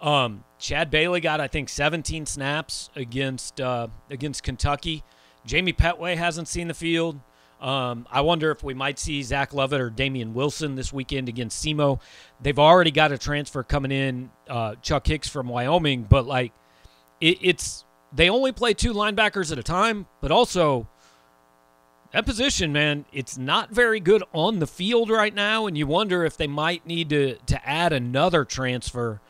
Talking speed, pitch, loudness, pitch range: 170 wpm, 145 Hz, -23 LUFS, 125-170 Hz